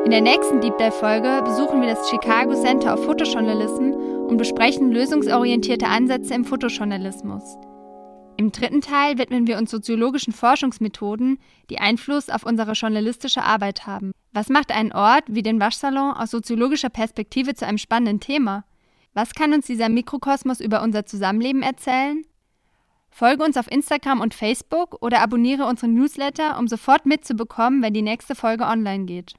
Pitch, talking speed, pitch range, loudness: 235 Hz, 155 wpm, 220-270 Hz, -20 LUFS